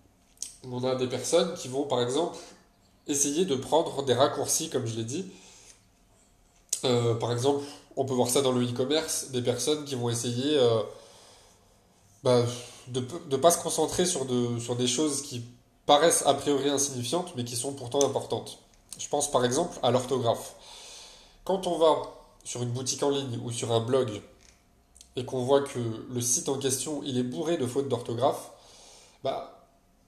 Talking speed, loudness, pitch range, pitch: 175 wpm, -28 LUFS, 120-140 Hz, 130 Hz